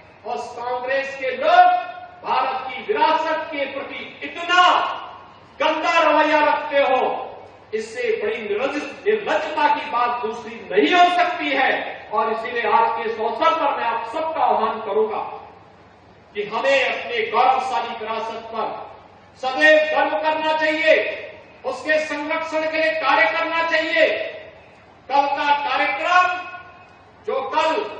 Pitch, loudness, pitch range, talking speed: 305 Hz, -20 LUFS, 245-340 Hz, 120 wpm